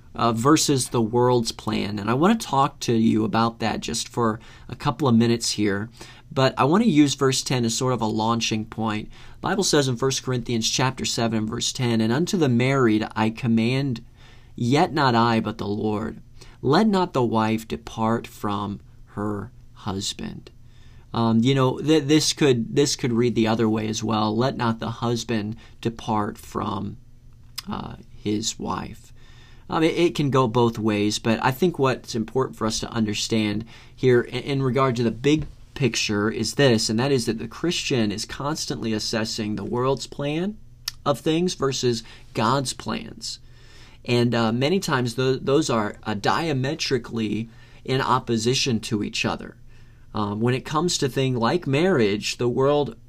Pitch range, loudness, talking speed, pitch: 115-135 Hz, -23 LUFS, 175 wpm, 120 Hz